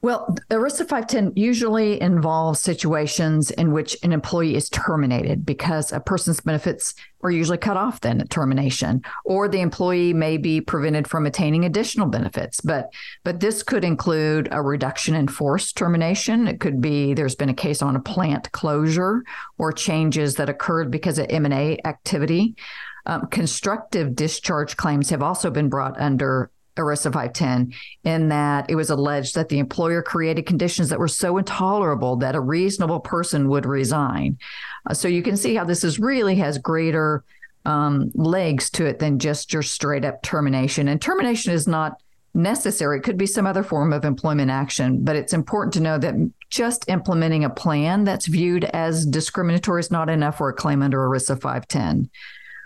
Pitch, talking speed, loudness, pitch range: 160 Hz, 175 wpm, -21 LUFS, 145-180 Hz